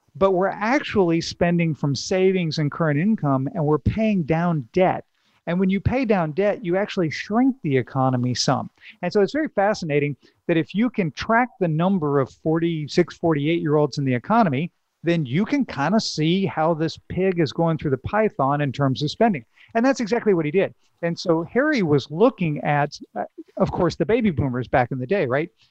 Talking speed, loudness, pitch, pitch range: 205 wpm, -22 LUFS, 170 Hz, 150-200 Hz